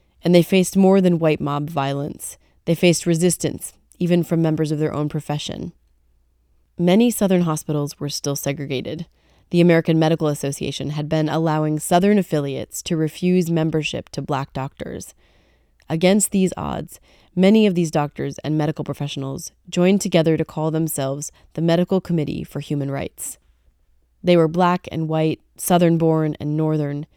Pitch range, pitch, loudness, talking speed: 145-175 Hz, 155 Hz, -20 LUFS, 150 wpm